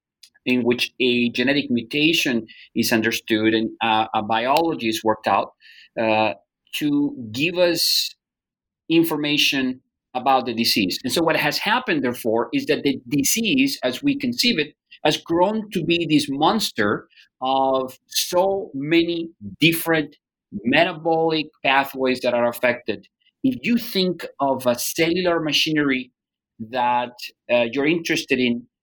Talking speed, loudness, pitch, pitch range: 130 wpm, -21 LUFS, 140 Hz, 120-170 Hz